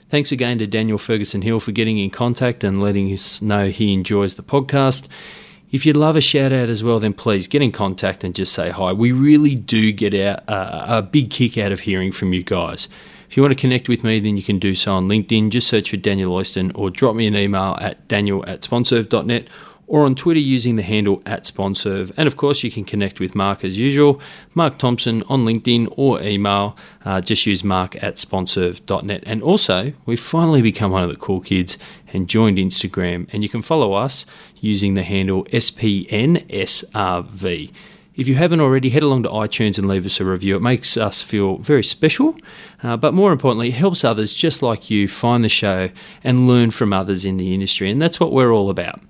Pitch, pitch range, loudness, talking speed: 110 Hz, 100-130 Hz, -17 LUFS, 210 wpm